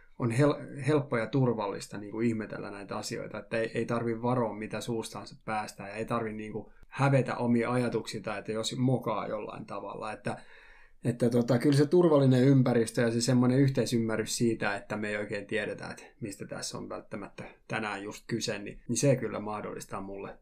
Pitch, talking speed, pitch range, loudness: 115 Hz, 175 wpm, 110-125 Hz, -30 LUFS